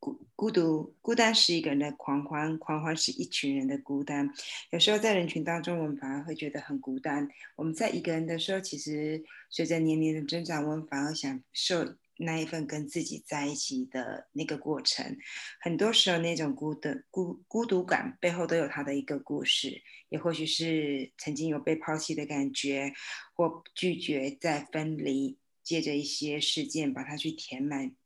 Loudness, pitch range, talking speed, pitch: -31 LUFS, 145-170 Hz, 275 characters per minute, 155 Hz